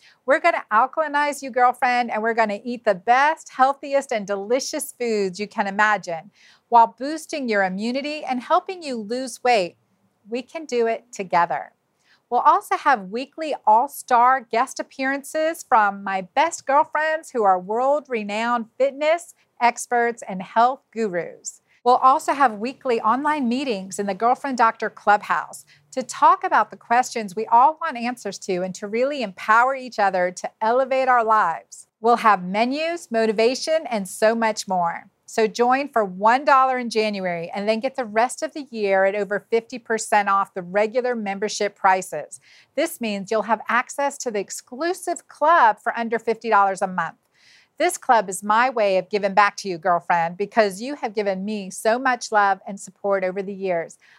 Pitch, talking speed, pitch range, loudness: 230 Hz, 170 wpm, 205-265 Hz, -21 LUFS